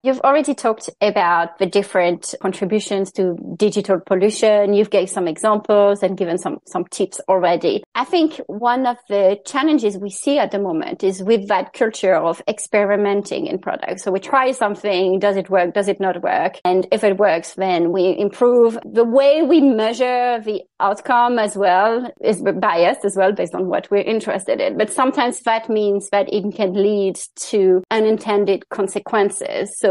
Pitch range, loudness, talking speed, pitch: 190-230 Hz, -18 LUFS, 175 wpm, 205 Hz